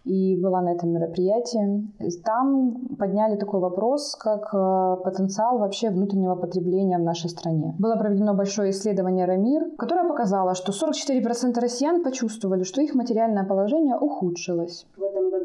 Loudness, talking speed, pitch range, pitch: -24 LUFS, 130 wpm, 185-235 Hz, 200 Hz